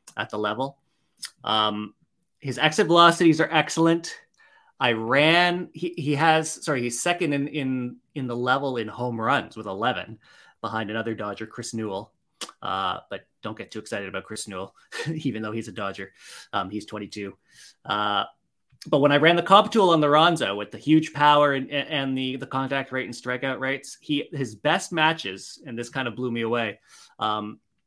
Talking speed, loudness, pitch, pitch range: 185 wpm, -24 LUFS, 130 Hz, 110-155 Hz